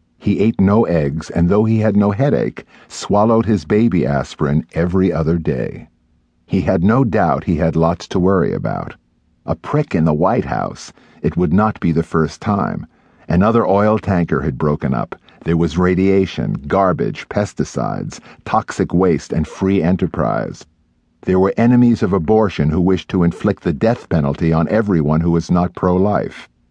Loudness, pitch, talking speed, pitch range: -16 LUFS, 85 Hz, 165 wpm, 80-100 Hz